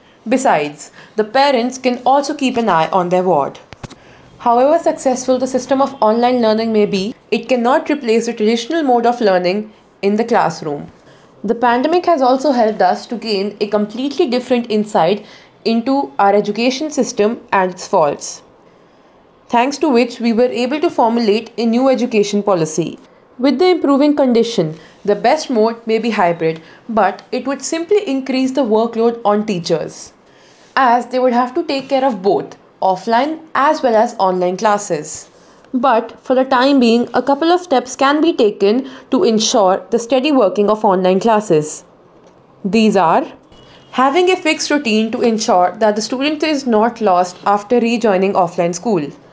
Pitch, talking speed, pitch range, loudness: 235 Hz, 165 wpm, 205-265 Hz, -15 LUFS